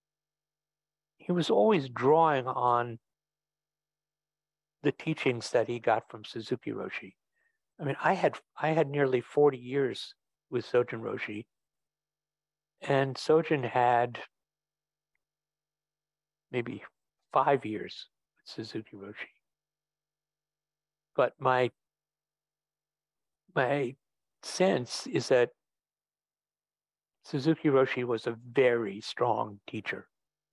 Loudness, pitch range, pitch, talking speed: -29 LUFS, 130-155 Hz, 155 Hz, 90 wpm